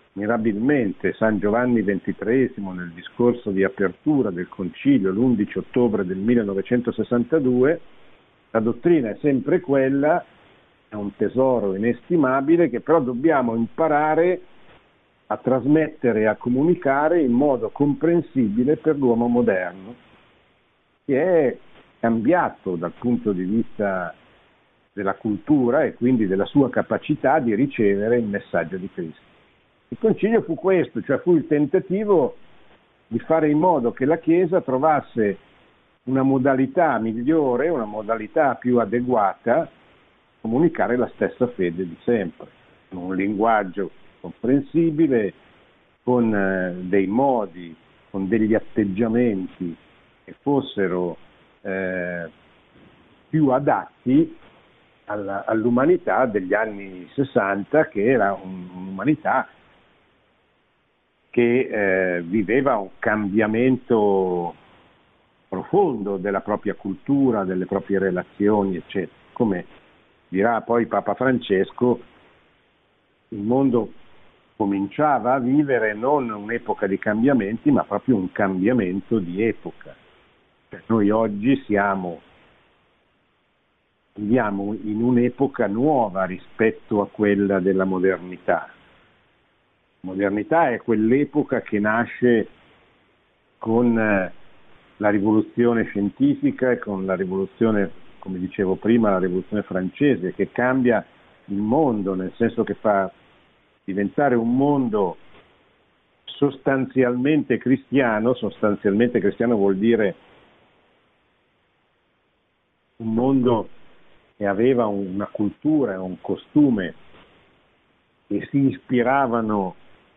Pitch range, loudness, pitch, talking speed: 100-130 Hz, -21 LUFS, 115 Hz, 100 wpm